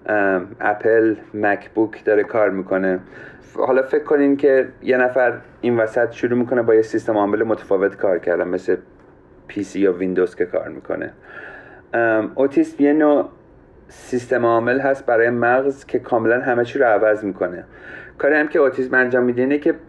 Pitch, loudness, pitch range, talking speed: 120 Hz, -18 LUFS, 105-130 Hz, 170 wpm